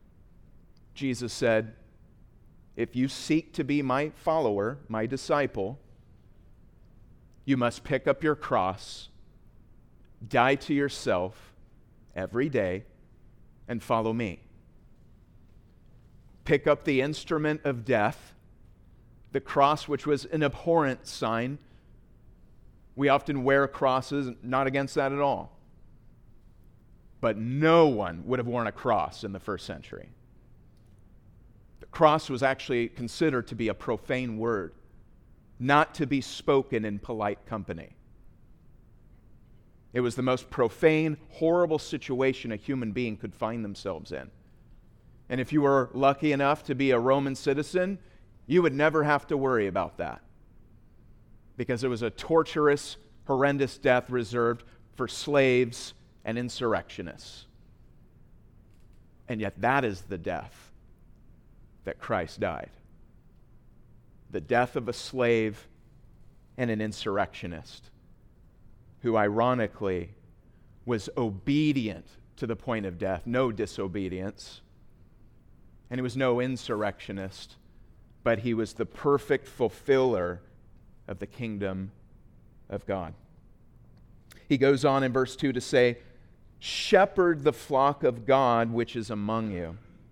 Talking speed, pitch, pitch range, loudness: 120 wpm, 120 Hz, 110-135 Hz, -28 LUFS